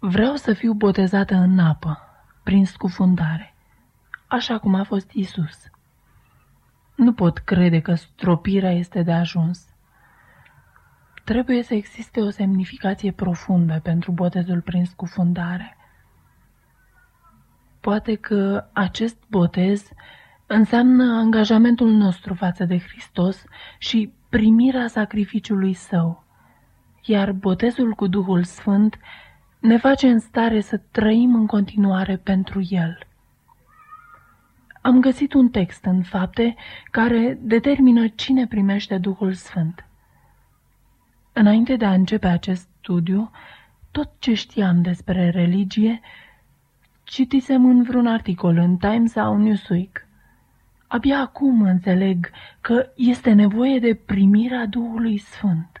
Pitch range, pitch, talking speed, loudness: 185-230 Hz, 205 Hz, 110 wpm, -19 LUFS